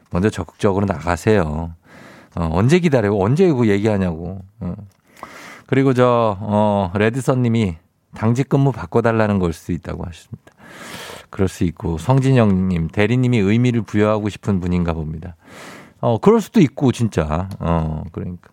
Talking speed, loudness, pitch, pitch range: 315 characters per minute, -18 LUFS, 100 Hz, 90-115 Hz